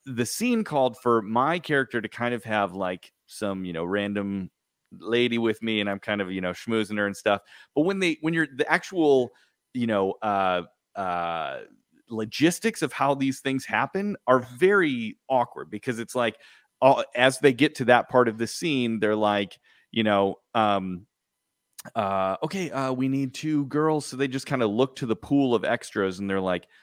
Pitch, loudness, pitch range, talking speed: 120 Hz, -25 LUFS, 100-140 Hz, 195 wpm